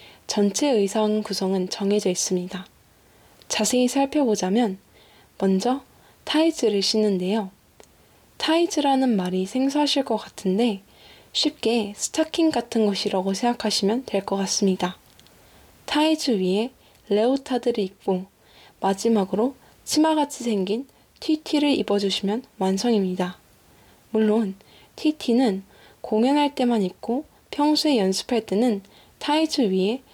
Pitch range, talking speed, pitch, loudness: 195-265 Hz, 260 characters per minute, 220 Hz, -23 LUFS